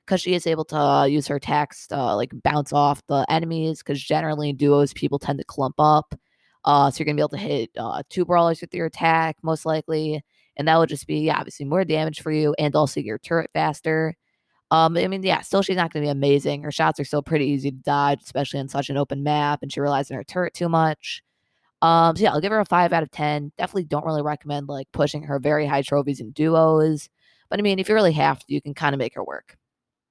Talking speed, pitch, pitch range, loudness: 255 wpm, 150 Hz, 145-160 Hz, -22 LUFS